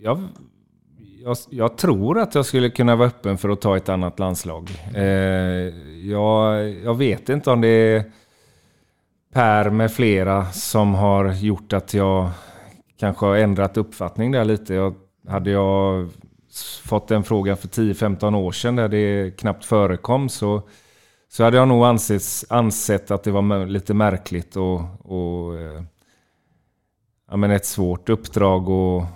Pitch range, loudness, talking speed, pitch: 95-110 Hz, -20 LUFS, 145 wpm, 100 Hz